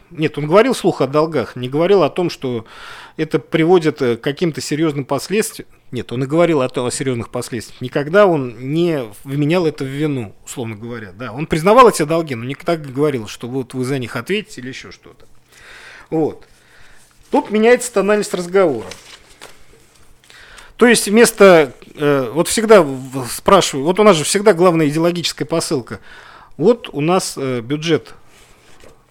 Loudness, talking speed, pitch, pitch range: -16 LUFS, 160 wpm, 155 Hz, 130-185 Hz